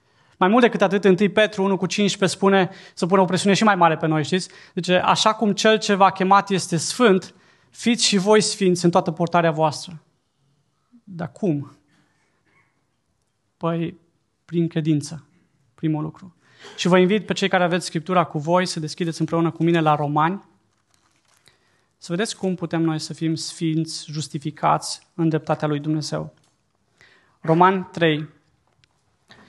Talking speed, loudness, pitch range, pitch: 155 wpm, -20 LUFS, 155-190 Hz, 165 Hz